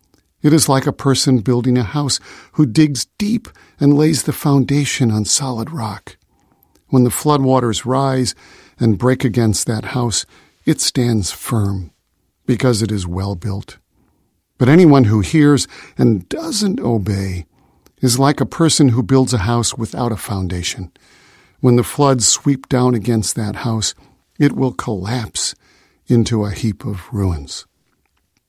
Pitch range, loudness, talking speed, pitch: 105-135 Hz, -16 LUFS, 145 wpm, 120 Hz